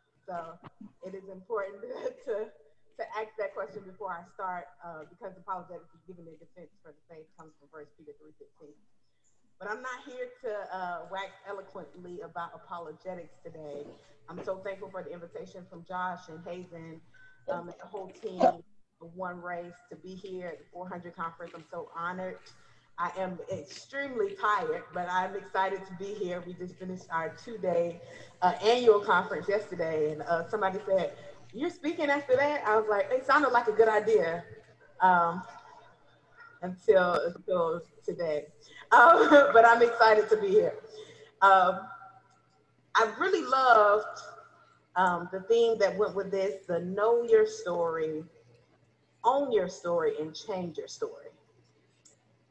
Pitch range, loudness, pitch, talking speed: 170-220 Hz, -28 LUFS, 190 Hz, 155 wpm